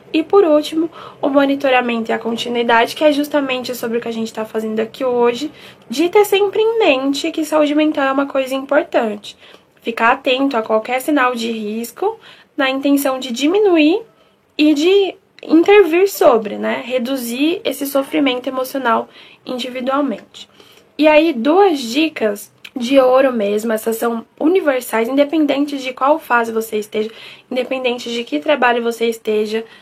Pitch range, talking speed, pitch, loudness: 235-305 Hz, 150 wpm, 270 Hz, -16 LUFS